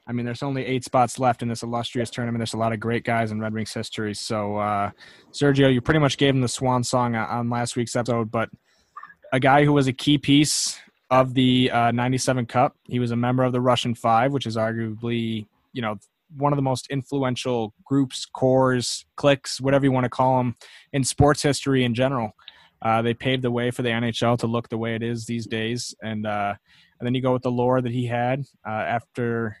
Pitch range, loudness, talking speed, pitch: 115-130 Hz, -23 LUFS, 225 wpm, 120 Hz